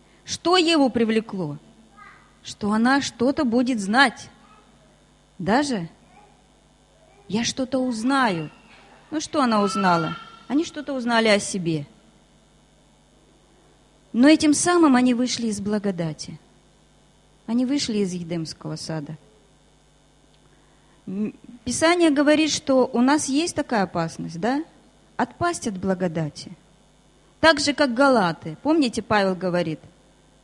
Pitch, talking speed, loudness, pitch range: 230 Hz, 105 wpm, -22 LUFS, 180-275 Hz